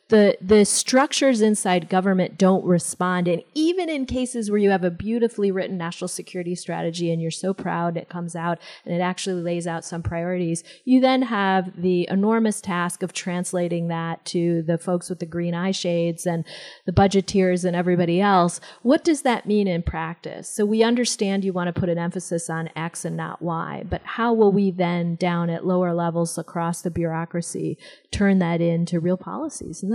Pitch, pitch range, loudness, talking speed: 180 Hz, 170-200 Hz, -22 LUFS, 190 wpm